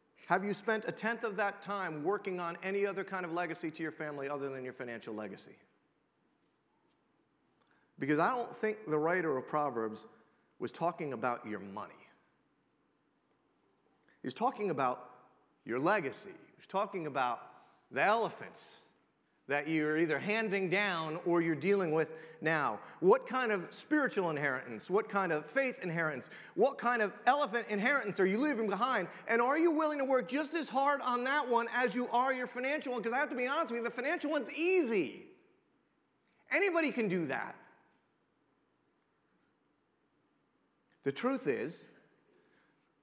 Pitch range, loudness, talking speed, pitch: 160-255 Hz, -34 LUFS, 155 wpm, 205 Hz